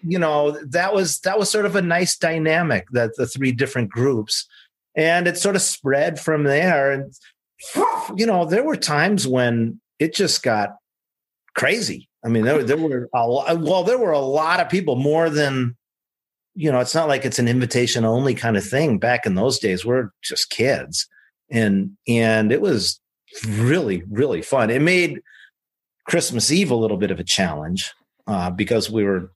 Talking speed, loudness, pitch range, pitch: 180 wpm, -20 LUFS, 115-170 Hz, 135 Hz